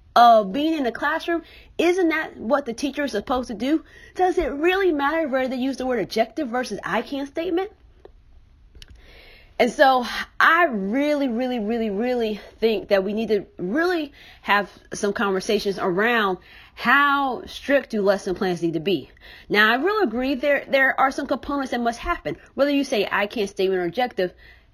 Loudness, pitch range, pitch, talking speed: -22 LUFS, 210-290 Hz, 255 Hz, 180 wpm